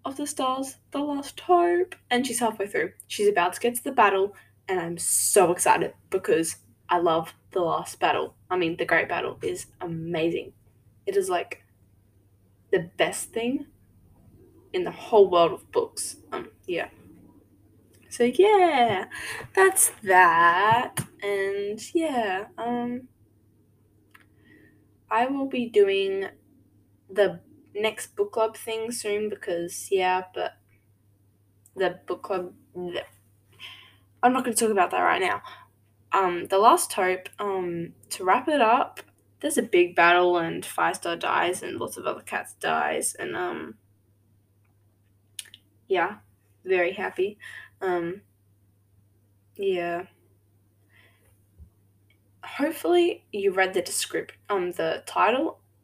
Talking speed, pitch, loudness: 130 wpm, 185 Hz, -25 LUFS